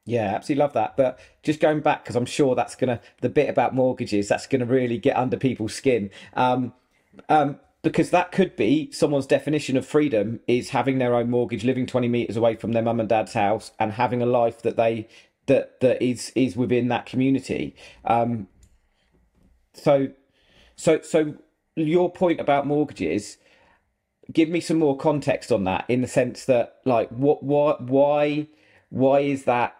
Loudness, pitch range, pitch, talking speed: -23 LUFS, 120-150 Hz, 130 Hz, 175 wpm